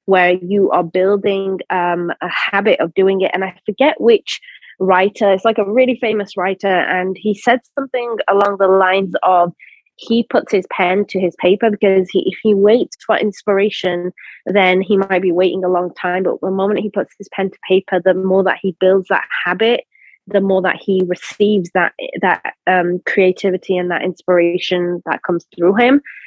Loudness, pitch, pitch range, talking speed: -15 LUFS, 190 Hz, 185-205 Hz, 190 wpm